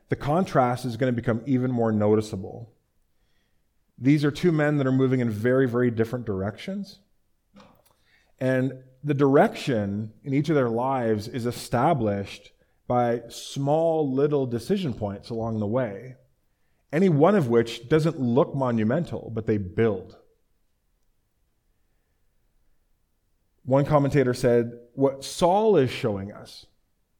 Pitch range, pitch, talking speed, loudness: 110-140 Hz, 125 Hz, 125 wpm, -24 LUFS